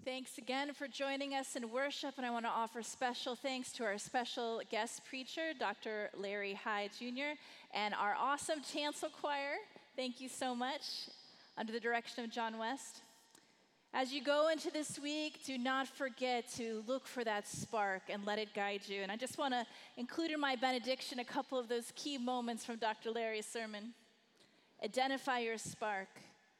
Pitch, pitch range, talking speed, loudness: 250 Hz, 225-275 Hz, 180 wpm, -41 LUFS